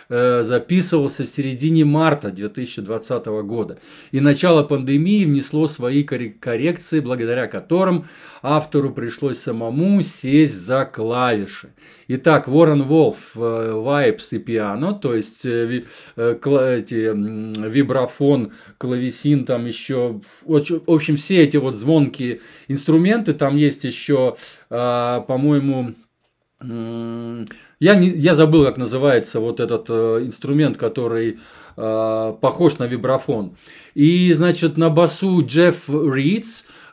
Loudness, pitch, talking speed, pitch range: -18 LUFS, 140 Hz, 105 wpm, 120-155 Hz